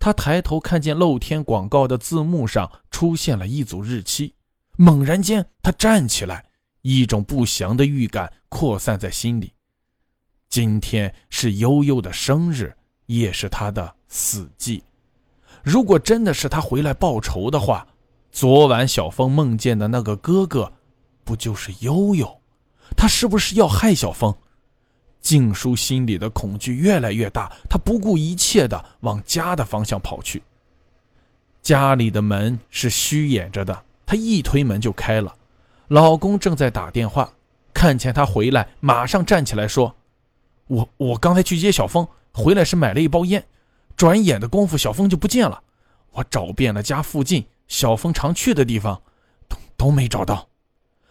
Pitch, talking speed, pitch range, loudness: 130 Hz, 225 characters per minute, 110-165 Hz, -19 LUFS